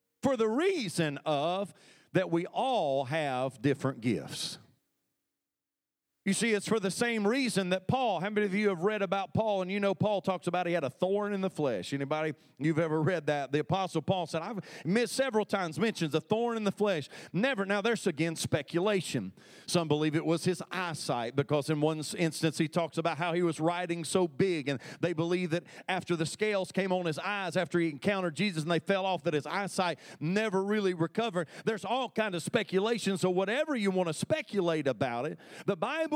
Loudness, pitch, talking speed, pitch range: -31 LUFS, 180 Hz, 205 wpm, 160-205 Hz